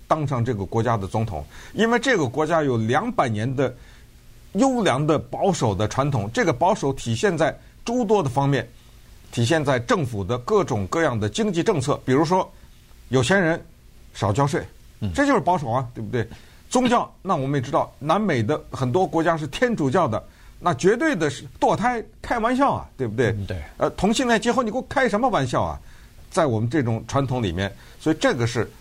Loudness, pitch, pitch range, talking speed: -22 LUFS, 140 Hz, 115-190 Hz, 285 characters per minute